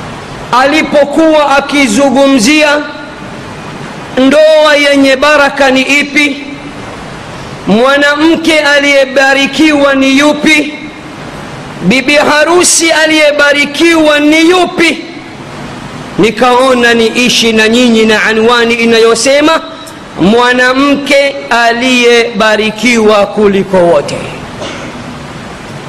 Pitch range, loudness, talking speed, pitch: 240-300 Hz, -6 LUFS, 65 wpm, 280 Hz